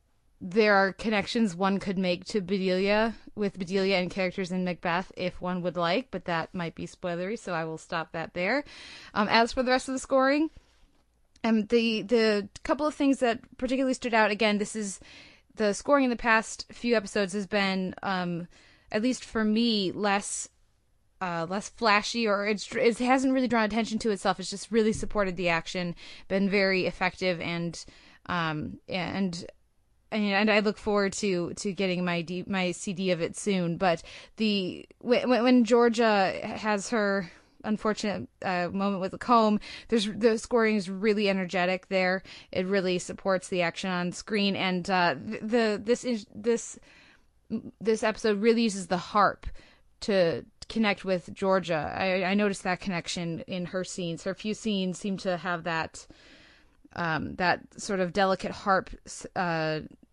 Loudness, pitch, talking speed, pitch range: -28 LUFS, 200 Hz, 170 wpm, 185-225 Hz